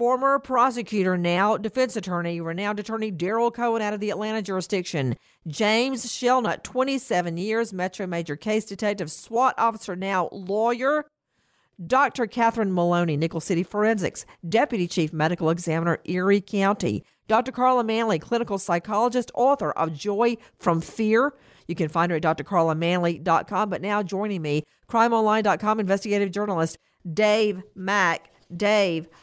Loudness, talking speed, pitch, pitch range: -24 LUFS, 130 wpm, 205 Hz, 175-230 Hz